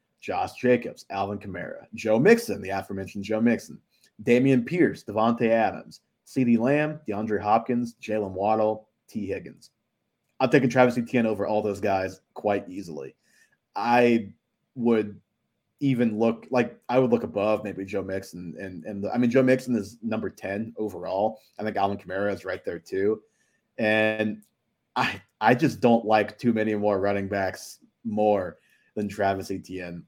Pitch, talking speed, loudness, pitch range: 110 Hz, 150 wpm, -25 LUFS, 100-120 Hz